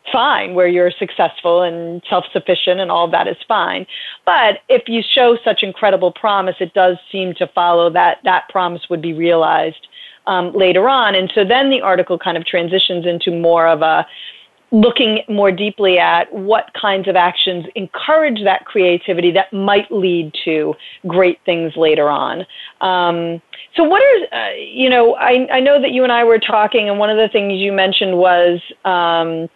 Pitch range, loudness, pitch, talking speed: 175-215 Hz, -14 LUFS, 190 Hz, 185 wpm